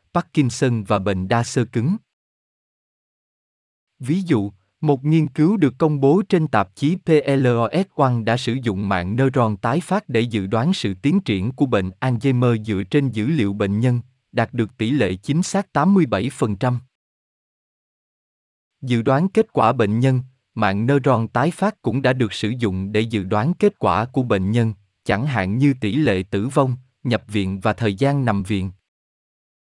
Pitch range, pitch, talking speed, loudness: 105-140 Hz, 120 Hz, 170 wpm, -20 LUFS